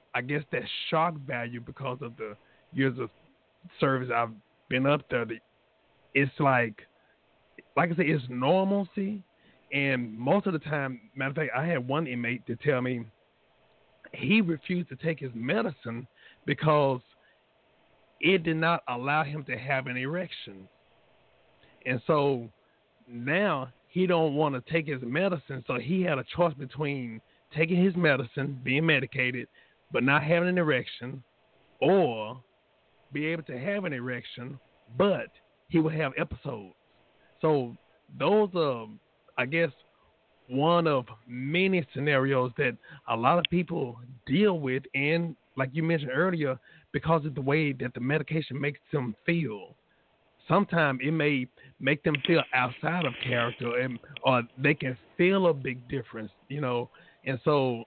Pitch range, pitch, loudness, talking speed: 125-165 Hz, 140 Hz, -28 LUFS, 150 wpm